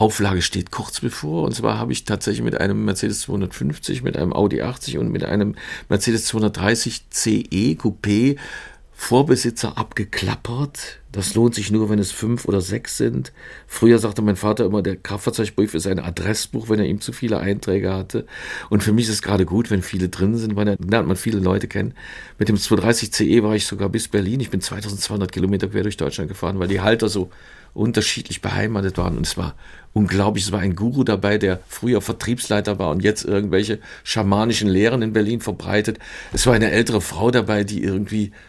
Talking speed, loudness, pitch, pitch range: 190 wpm, -20 LUFS, 105 Hz, 100-110 Hz